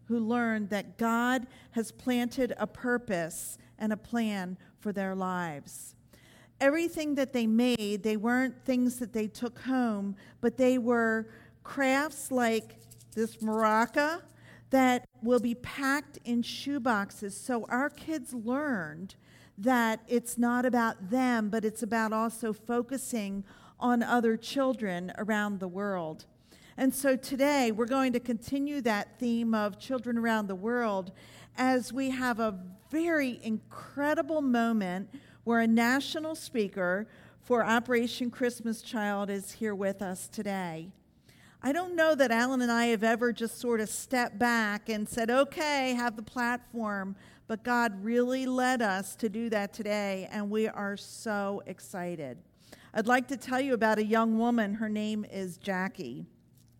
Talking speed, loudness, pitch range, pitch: 145 wpm, -30 LUFS, 210-250 Hz, 230 Hz